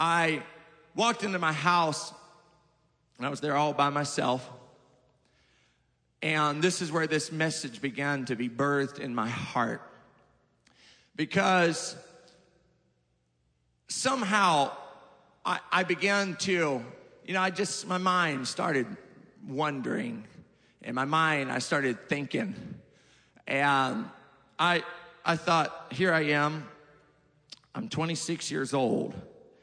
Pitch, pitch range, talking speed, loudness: 155 Hz, 140-175 Hz, 115 wpm, -29 LUFS